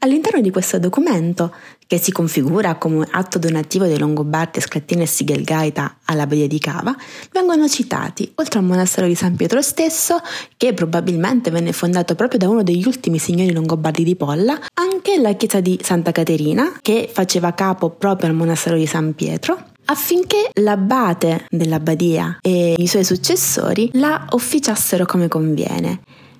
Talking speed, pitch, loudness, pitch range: 150 wpm, 180 Hz, -17 LUFS, 165-240 Hz